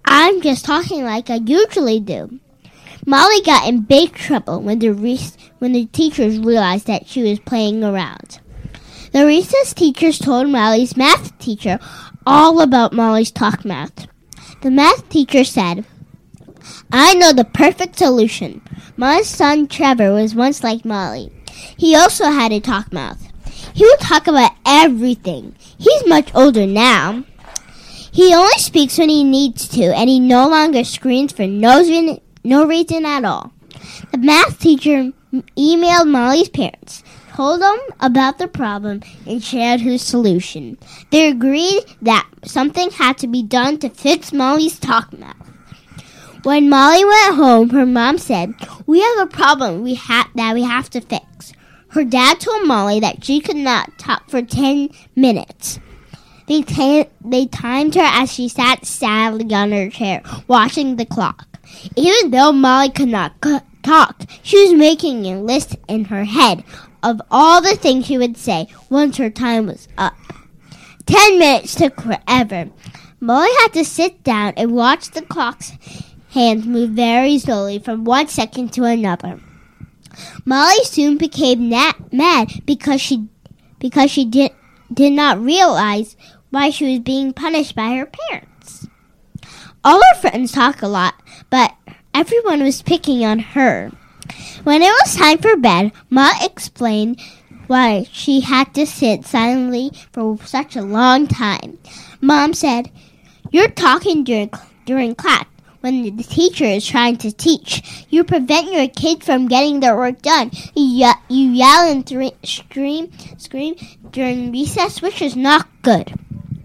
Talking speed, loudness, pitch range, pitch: 150 wpm, -13 LUFS, 230-300 Hz, 260 Hz